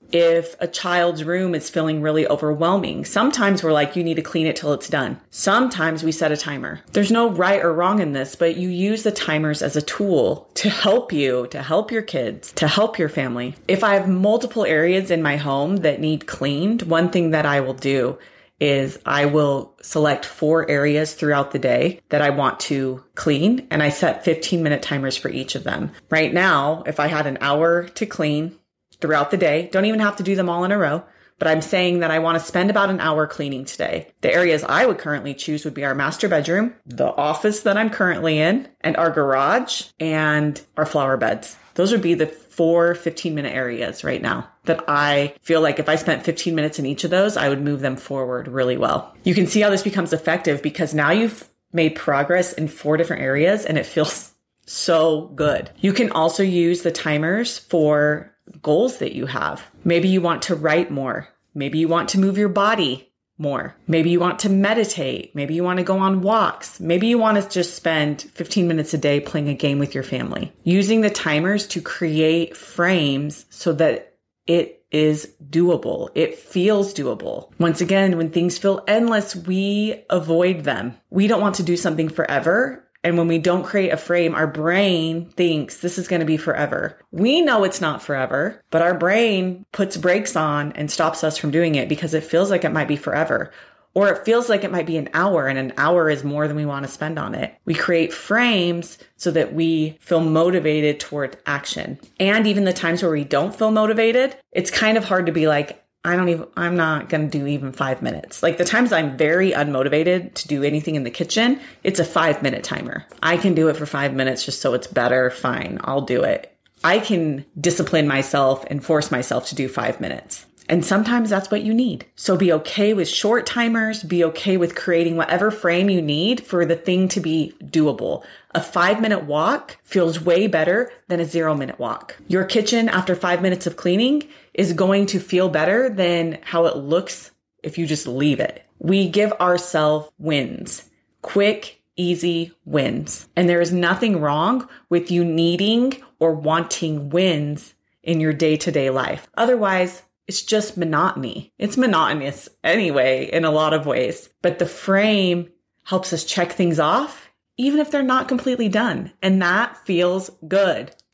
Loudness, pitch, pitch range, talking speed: -20 LUFS, 170 Hz, 150-190 Hz, 200 wpm